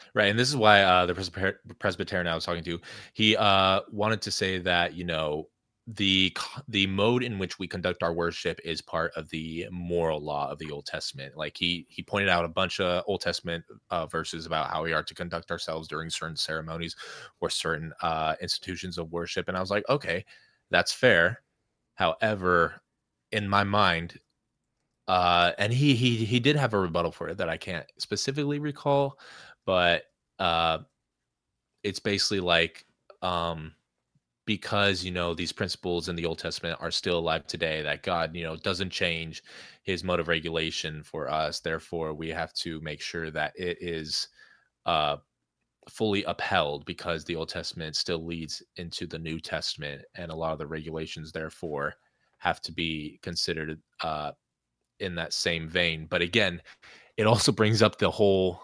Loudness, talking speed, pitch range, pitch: -28 LUFS, 175 wpm, 80-100 Hz, 85 Hz